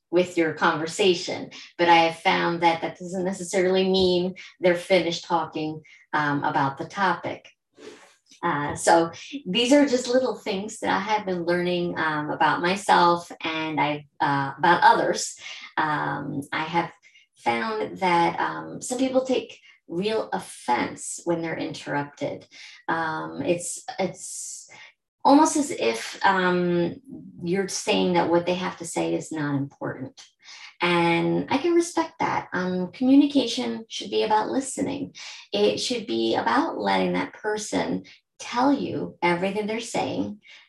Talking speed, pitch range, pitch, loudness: 140 wpm, 165-215 Hz, 180 Hz, -24 LUFS